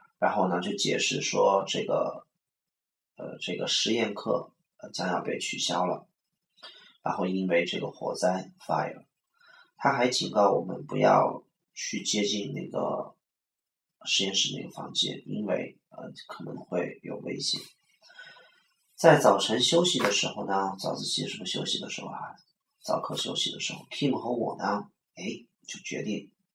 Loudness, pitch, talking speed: -28 LUFS, 105 Hz, 225 characters per minute